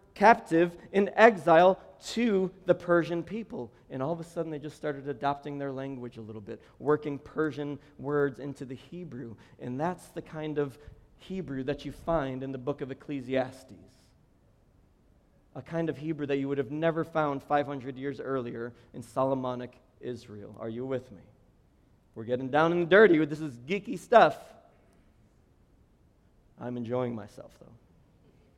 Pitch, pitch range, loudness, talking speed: 140 Hz, 125-165 Hz, -29 LUFS, 155 wpm